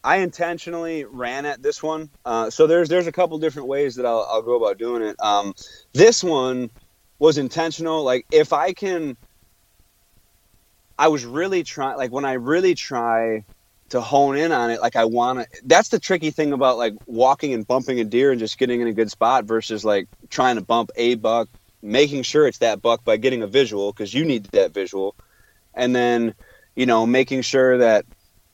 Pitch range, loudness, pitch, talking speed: 115-155 Hz, -20 LUFS, 125 Hz, 200 wpm